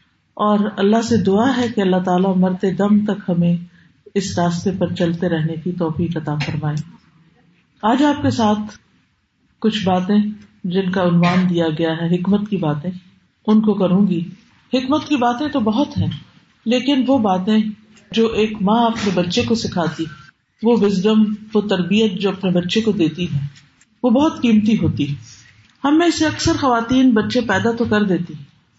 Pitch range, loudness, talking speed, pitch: 175-220 Hz, -18 LUFS, 170 wpm, 200 Hz